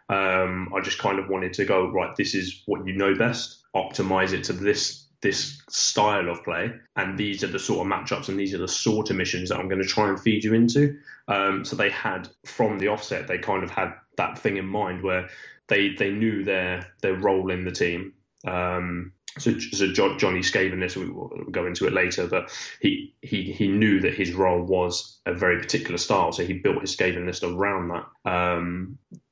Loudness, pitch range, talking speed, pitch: -25 LUFS, 90-105 Hz, 215 wpm, 95 Hz